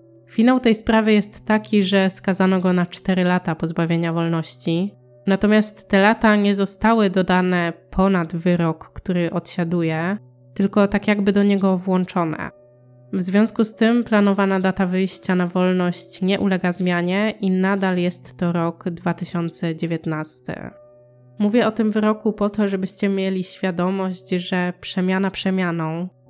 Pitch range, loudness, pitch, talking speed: 170-200 Hz, -20 LUFS, 185 Hz, 135 wpm